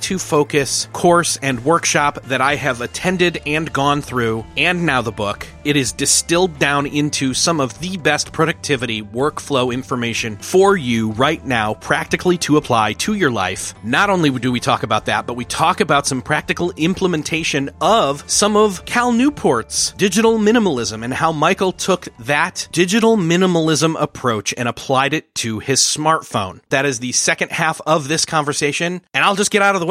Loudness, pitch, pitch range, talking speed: -17 LUFS, 150 Hz, 125-175 Hz, 180 wpm